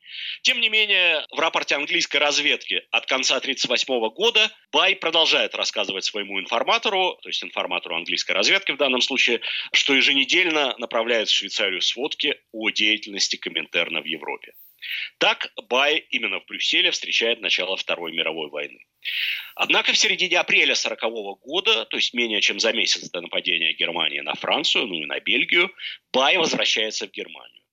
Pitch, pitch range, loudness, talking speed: 145 Hz, 115-195 Hz, -20 LUFS, 150 wpm